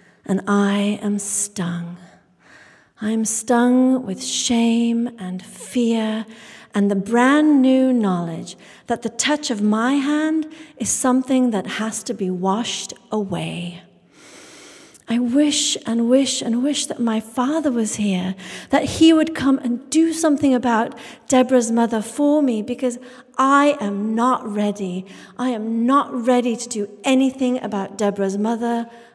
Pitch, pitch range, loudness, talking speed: 235 Hz, 205-255 Hz, -19 LUFS, 140 wpm